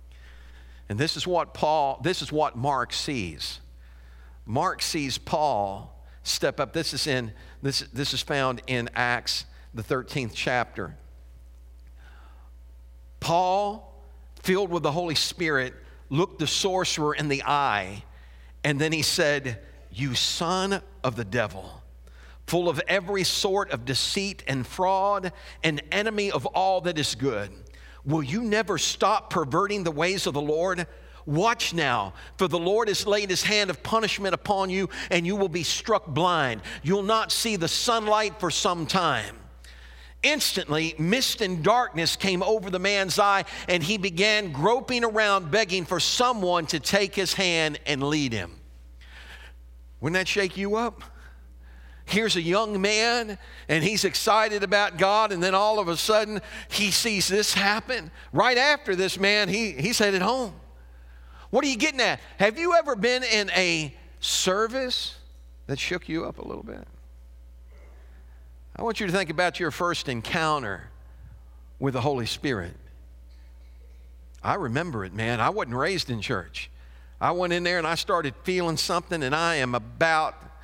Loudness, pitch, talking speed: -25 LUFS, 160 Hz, 155 wpm